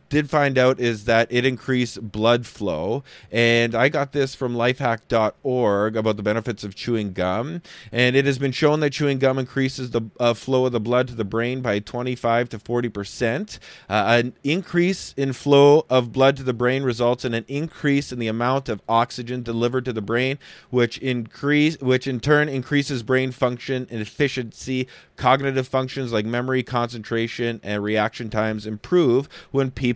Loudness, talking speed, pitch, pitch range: -22 LUFS, 175 wpm, 125 Hz, 115-135 Hz